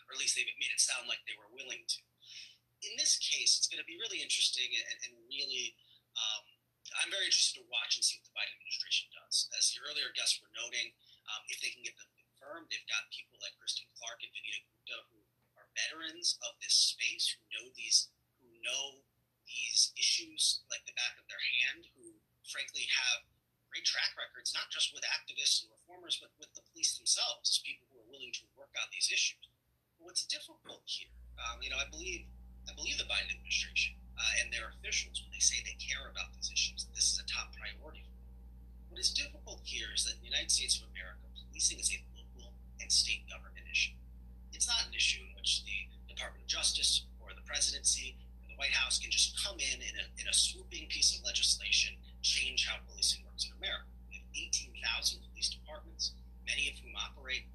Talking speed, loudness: 210 wpm, -34 LUFS